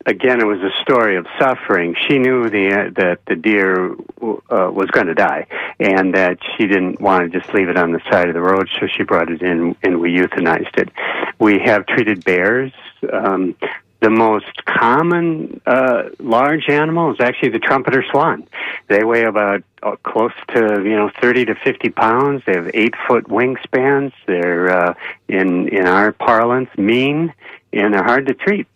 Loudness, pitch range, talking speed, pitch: -15 LUFS, 95-130 Hz, 185 wpm, 105 Hz